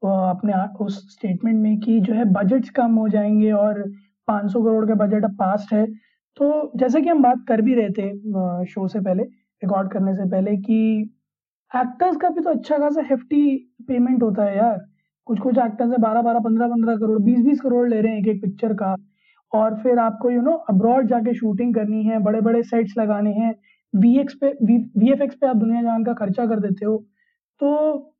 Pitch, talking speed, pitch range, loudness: 225 Hz, 165 wpm, 210-245 Hz, -20 LUFS